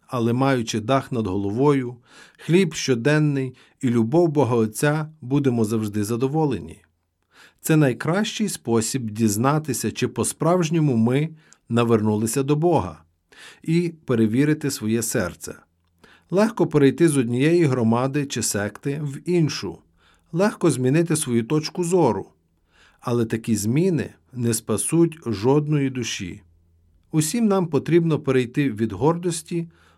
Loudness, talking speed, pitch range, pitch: -22 LUFS, 110 wpm, 110-155 Hz, 130 Hz